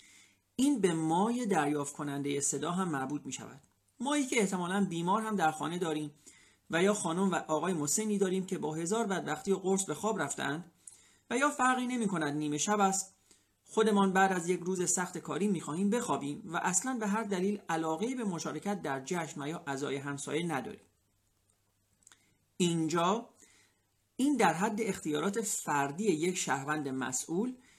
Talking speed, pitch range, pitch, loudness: 165 wpm, 150-205 Hz, 175 Hz, -32 LUFS